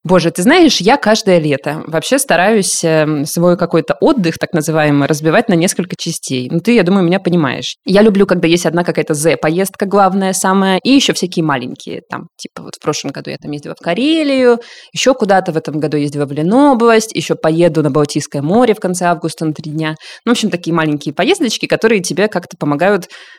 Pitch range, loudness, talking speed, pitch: 160-210 Hz, -13 LUFS, 200 wpm, 175 Hz